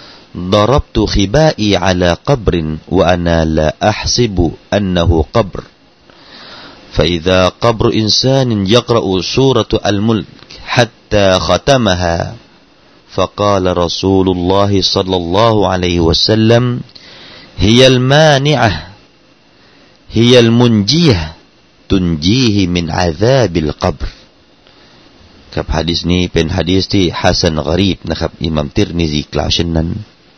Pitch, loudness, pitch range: 95 Hz, -12 LUFS, 85-110 Hz